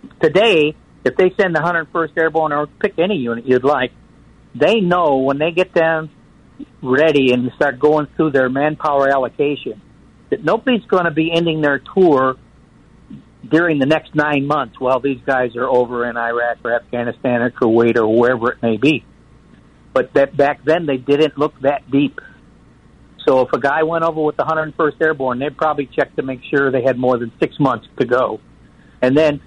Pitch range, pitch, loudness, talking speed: 125-160 Hz, 145 Hz, -16 LUFS, 185 wpm